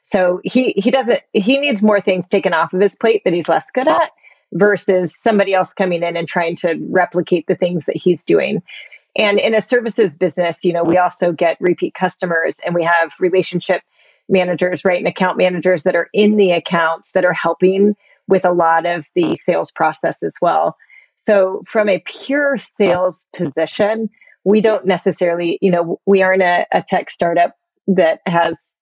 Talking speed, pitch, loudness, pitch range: 185 wpm, 185 Hz, -16 LUFS, 175-205 Hz